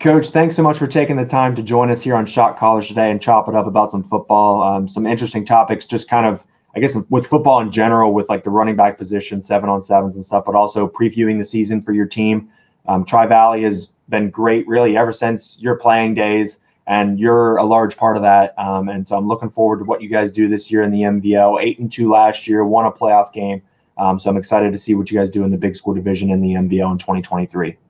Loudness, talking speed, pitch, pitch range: -15 LUFS, 255 wpm, 105 Hz, 100-115 Hz